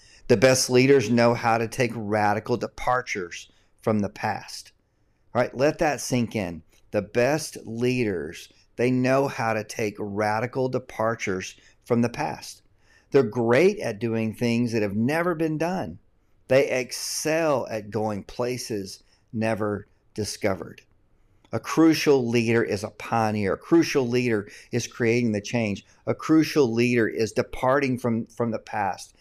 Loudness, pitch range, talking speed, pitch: -24 LUFS, 105-125 Hz, 145 wpm, 115 Hz